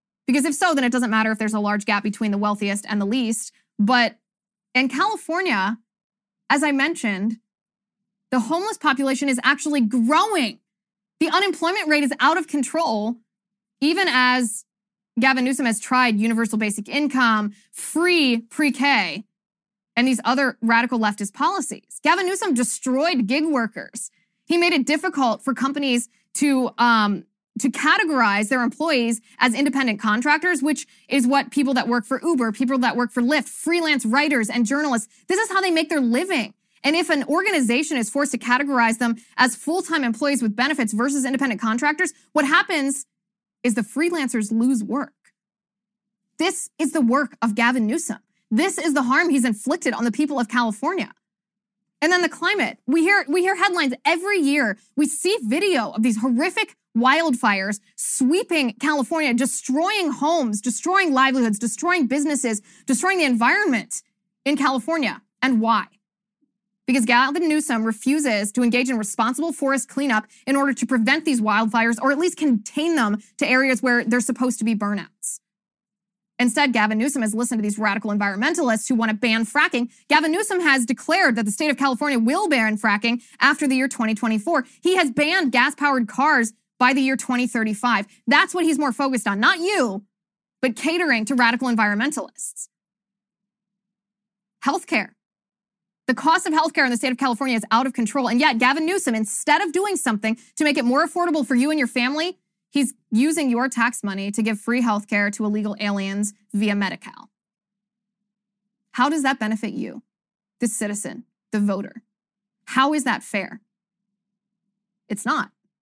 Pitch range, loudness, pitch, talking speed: 215-290 Hz, -20 LUFS, 245 Hz, 165 wpm